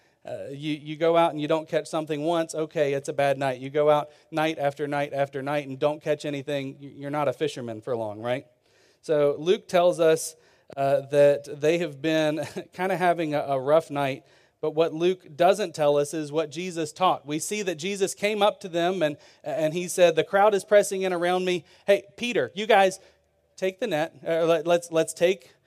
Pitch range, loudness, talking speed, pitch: 145-180 Hz, -25 LUFS, 230 wpm, 160 Hz